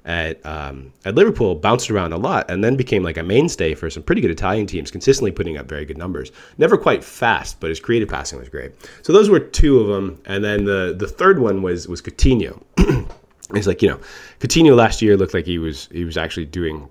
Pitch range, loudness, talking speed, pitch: 80-100 Hz, -18 LUFS, 230 wpm, 85 Hz